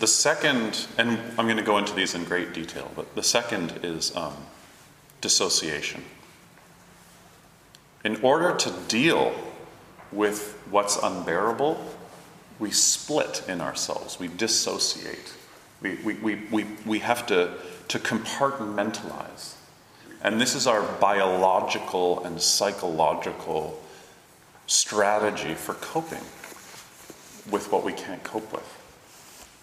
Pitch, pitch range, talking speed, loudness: 105 Hz, 95-110 Hz, 115 wpm, -25 LUFS